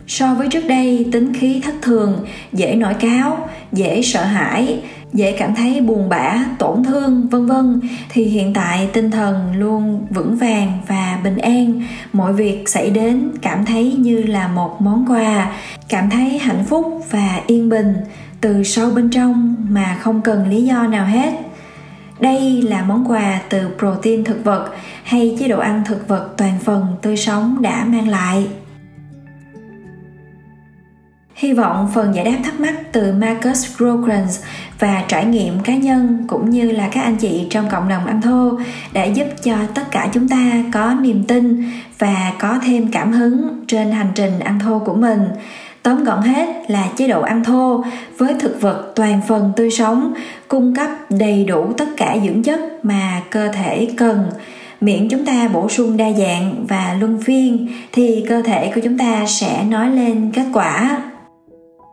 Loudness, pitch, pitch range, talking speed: -16 LUFS, 225 Hz, 200-245 Hz, 175 wpm